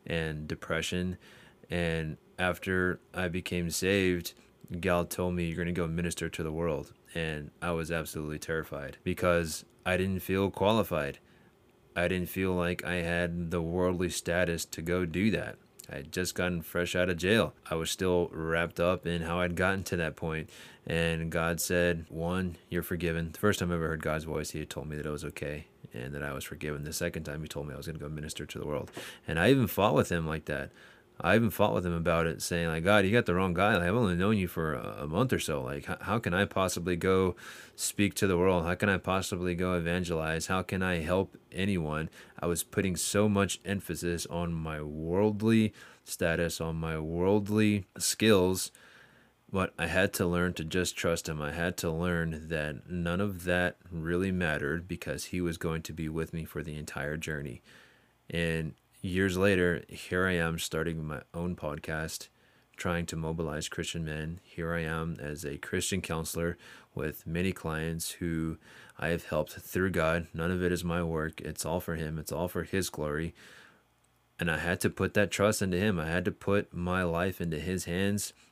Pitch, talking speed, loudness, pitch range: 85 Hz, 205 wpm, -31 LUFS, 80-90 Hz